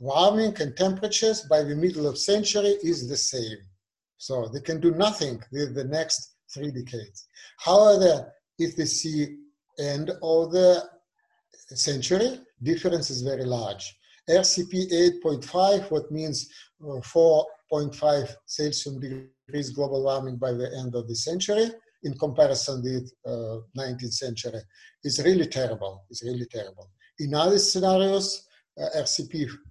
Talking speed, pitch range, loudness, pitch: 130 wpm, 130-175 Hz, -25 LUFS, 150 Hz